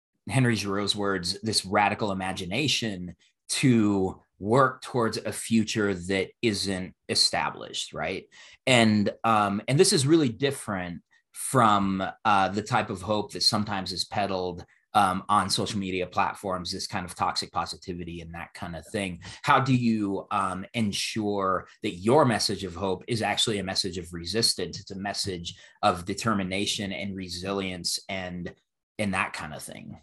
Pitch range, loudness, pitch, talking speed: 95-110 Hz, -26 LUFS, 100 Hz, 150 wpm